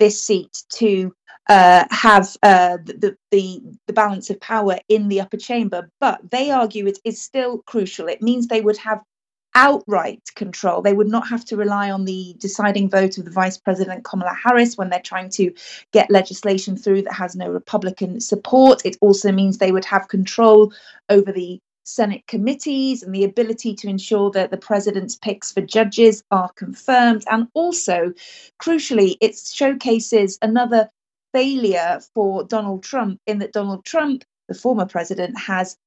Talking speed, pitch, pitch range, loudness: 165 wpm, 205 Hz, 190-225 Hz, -18 LUFS